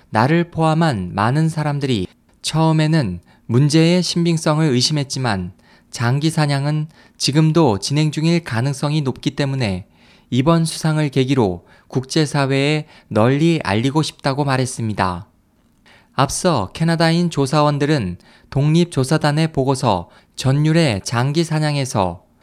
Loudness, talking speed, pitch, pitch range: -18 LUFS, 275 characters per minute, 145 Hz, 120-160 Hz